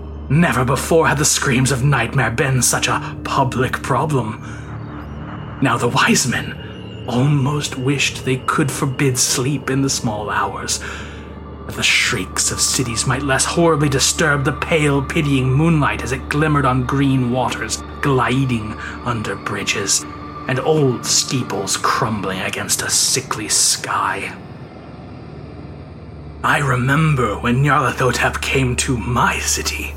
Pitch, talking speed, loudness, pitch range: 130 Hz, 130 wpm, -17 LUFS, 105-145 Hz